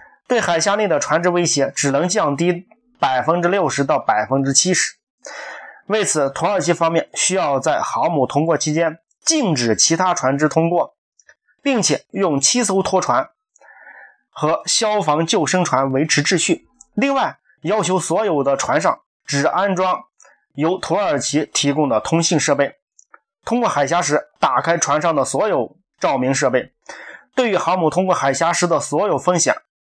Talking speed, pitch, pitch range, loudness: 235 characters per minute, 170 Hz, 145-205 Hz, -18 LUFS